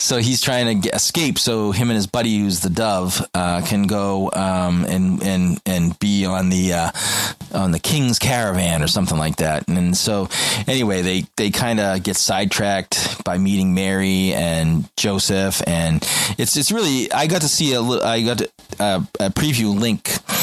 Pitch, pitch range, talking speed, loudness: 95 Hz, 90-115 Hz, 180 wpm, -18 LUFS